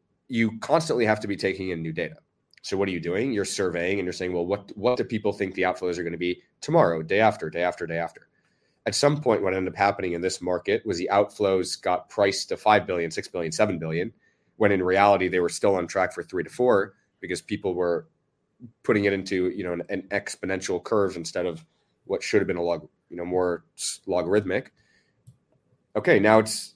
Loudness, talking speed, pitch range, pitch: -25 LUFS, 220 wpm, 90-105 Hz, 95 Hz